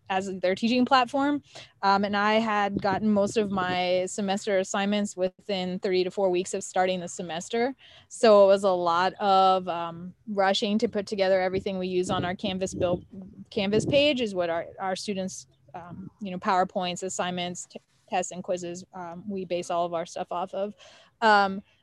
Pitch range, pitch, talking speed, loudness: 180-205 Hz, 190 Hz, 185 wpm, -26 LUFS